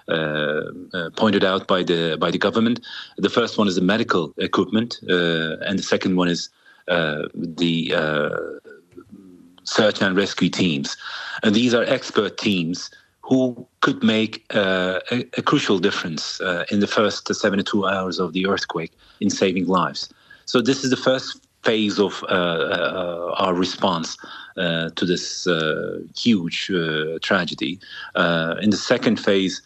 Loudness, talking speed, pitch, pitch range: -21 LUFS, 155 wpm, 95 Hz, 85-110 Hz